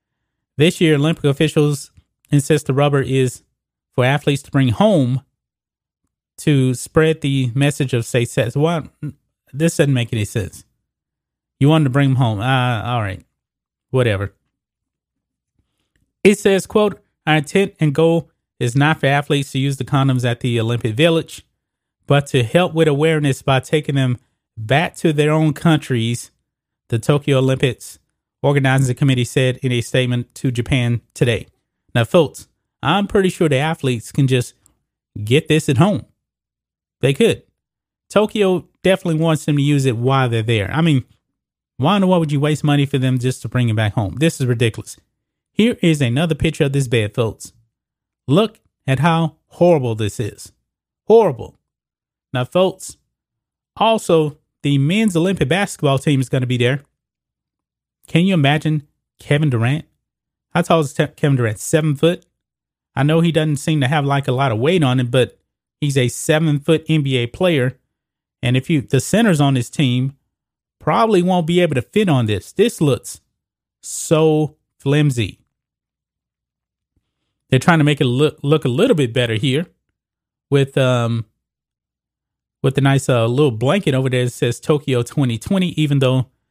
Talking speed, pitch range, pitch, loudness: 165 wpm, 125-155 Hz, 140 Hz, -17 LUFS